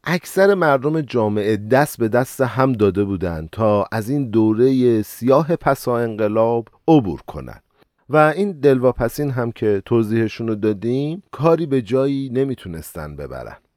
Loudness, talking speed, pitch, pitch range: -18 LUFS, 135 wpm, 125 Hz, 110-140 Hz